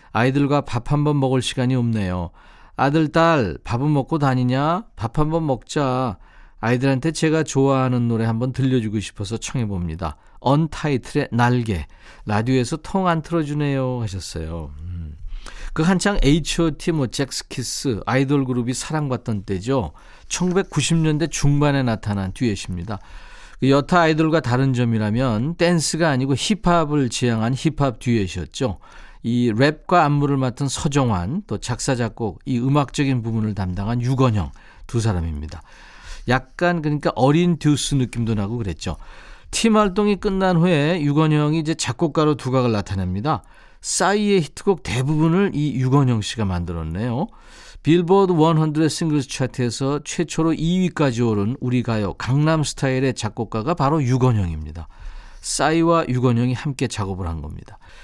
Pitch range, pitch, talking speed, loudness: 115-155 Hz, 130 Hz, 315 characters per minute, -20 LUFS